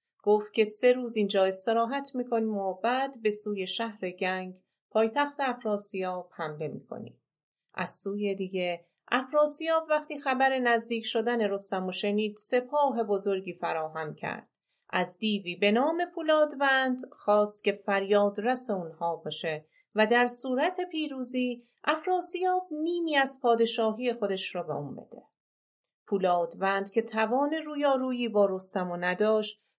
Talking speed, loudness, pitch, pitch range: 130 wpm, -27 LUFS, 220 Hz, 195-265 Hz